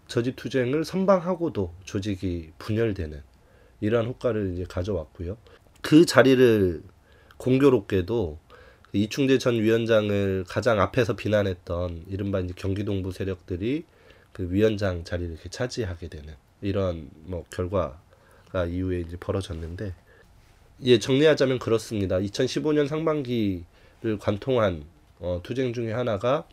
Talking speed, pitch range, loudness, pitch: 285 characters per minute, 90-120 Hz, -25 LUFS, 100 Hz